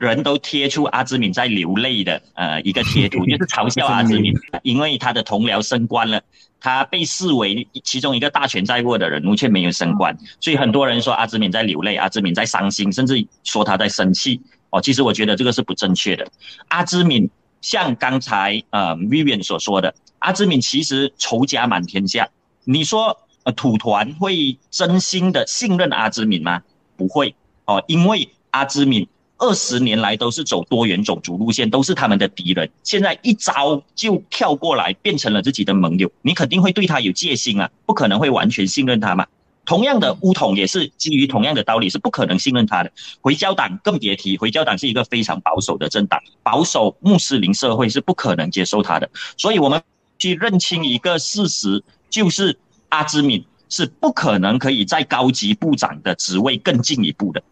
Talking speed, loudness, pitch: 295 characters per minute, -18 LUFS, 135 Hz